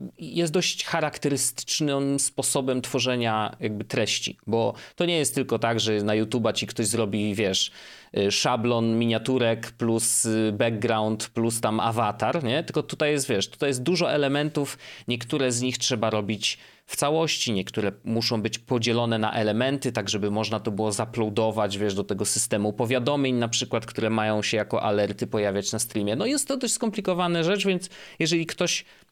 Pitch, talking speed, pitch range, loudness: 115 Hz, 165 wpm, 110-140 Hz, -25 LUFS